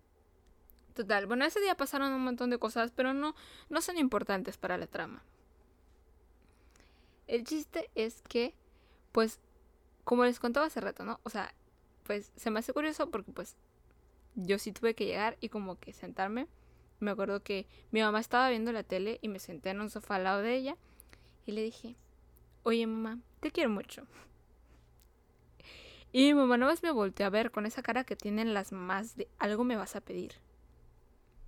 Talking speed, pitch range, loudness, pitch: 180 wpm, 190-245 Hz, -34 LUFS, 220 Hz